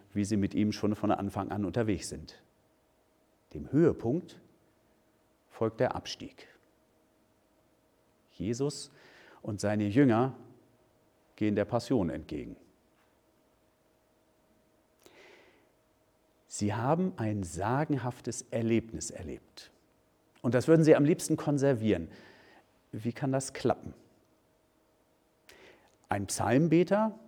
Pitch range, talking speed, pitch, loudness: 105-135 Hz, 90 wpm, 115 Hz, -30 LUFS